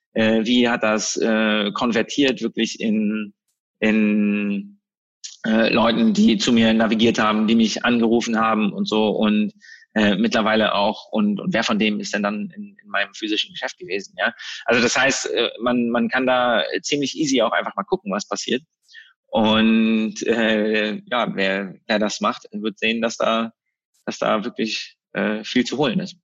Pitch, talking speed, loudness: 115 Hz, 170 wpm, -20 LUFS